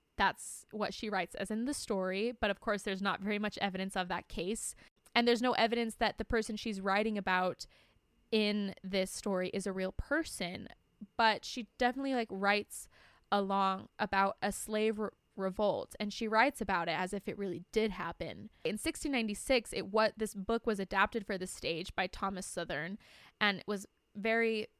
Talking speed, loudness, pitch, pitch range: 185 wpm, -35 LUFS, 210 Hz, 195-225 Hz